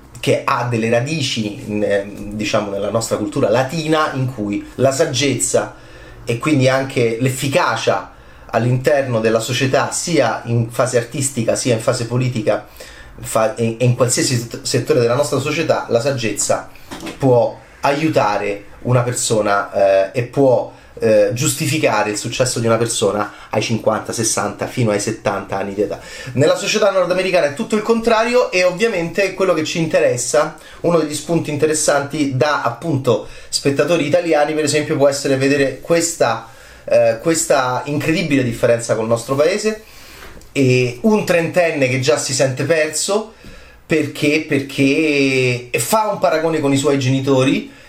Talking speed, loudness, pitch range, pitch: 140 wpm, -17 LUFS, 120-155 Hz, 135 Hz